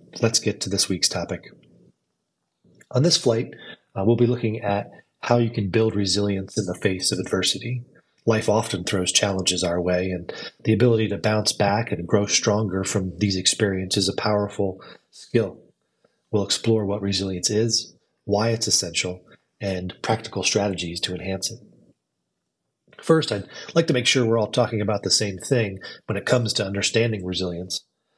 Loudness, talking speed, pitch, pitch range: -22 LUFS, 170 wpm, 105 Hz, 95-115 Hz